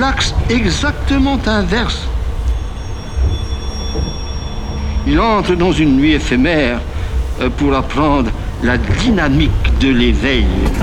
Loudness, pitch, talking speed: -15 LUFS, 90 Hz, 85 wpm